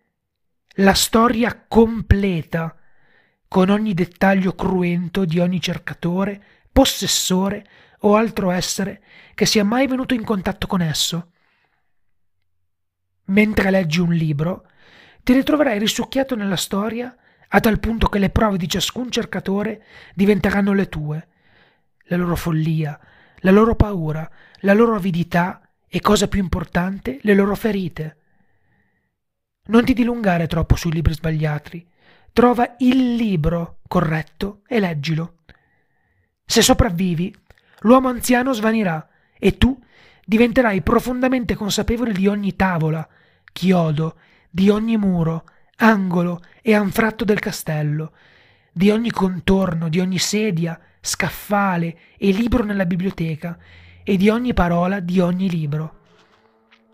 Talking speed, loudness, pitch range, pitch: 120 wpm, -19 LUFS, 165-215 Hz, 190 Hz